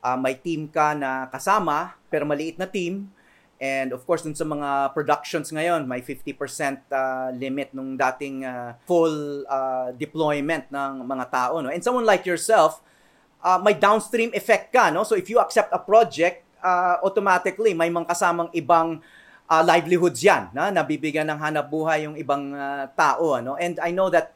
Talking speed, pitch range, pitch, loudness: 175 wpm, 140-175 Hz, 155 Hz, -23 LUFS